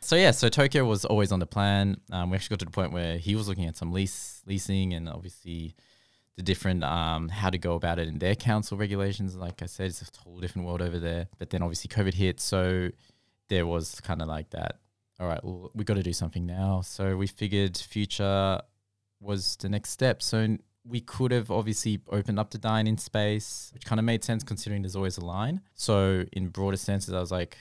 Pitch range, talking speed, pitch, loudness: 90-105 Hz, 230 wpm, 100 Hz, -29 LUFS